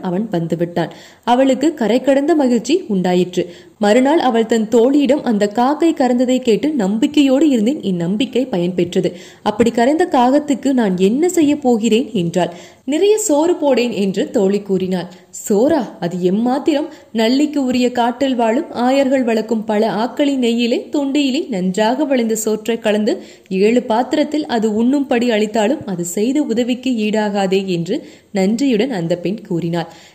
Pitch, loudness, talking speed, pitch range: 235 Hz, -16 LUFS, 125 wpm, 195-275 Hz